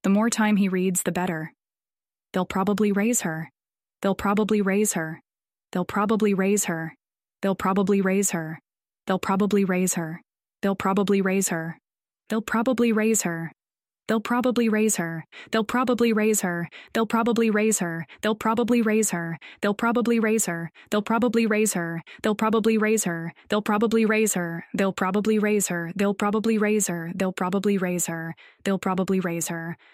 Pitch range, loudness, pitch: 175-220 Hz, -24 LUFS, 200 Hz